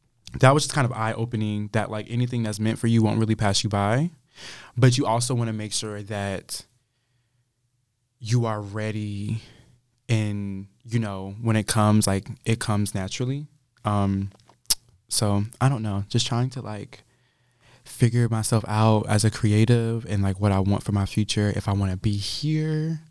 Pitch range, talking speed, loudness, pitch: 105-125 Hz, 175 wpm, -24 LUFS, 110 Hz